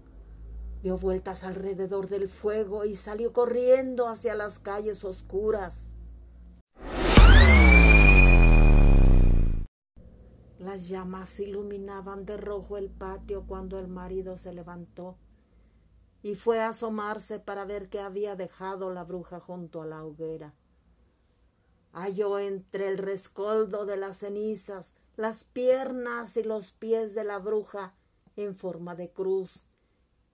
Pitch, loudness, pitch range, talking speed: 195 Hz, -25 LUFS, 175-210 Hz, 115 wpm